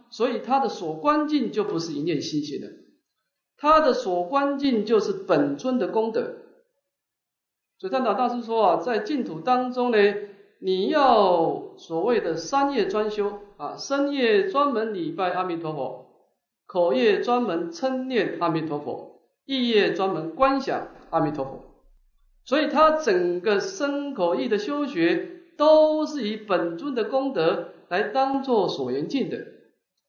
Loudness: -24 LUFS